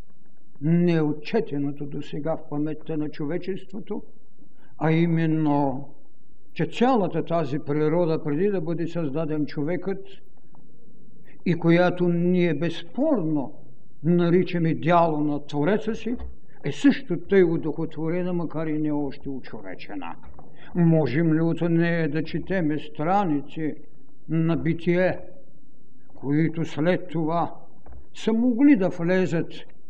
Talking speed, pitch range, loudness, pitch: 105 wpm, 150-180 Hz, -24 LUFS, 165 Hz